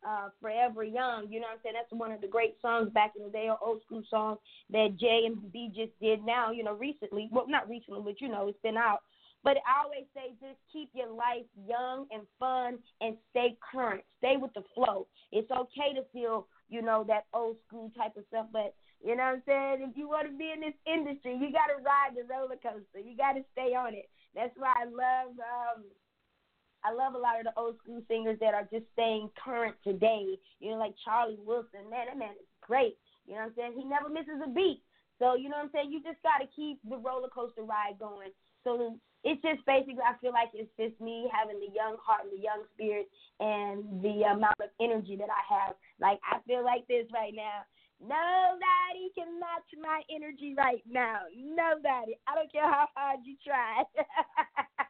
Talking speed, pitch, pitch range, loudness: 220 wpm, 235 Hz, 220-275 Hz, -33 LUFS